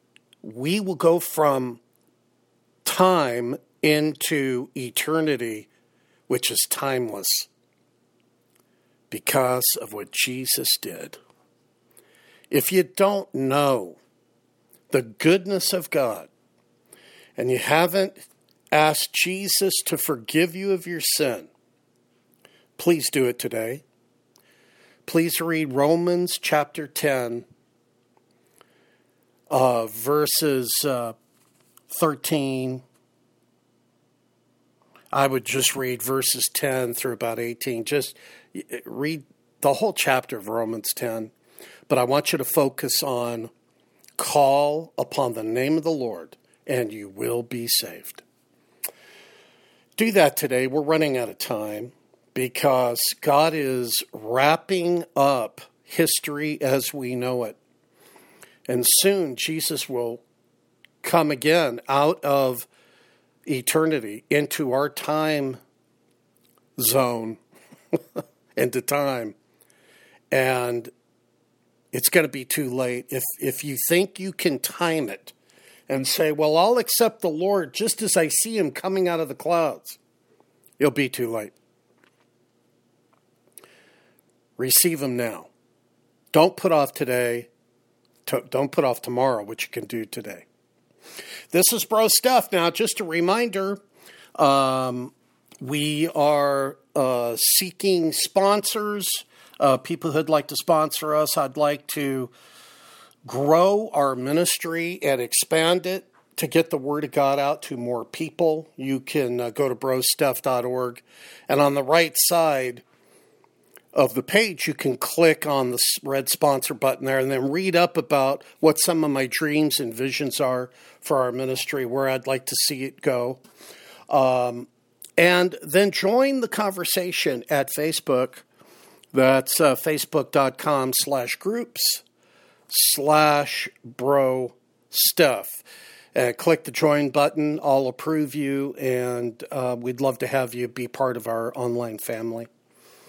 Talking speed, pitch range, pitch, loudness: 120 wpm, 125-165 Hz, 140 Hz, -22 LUFS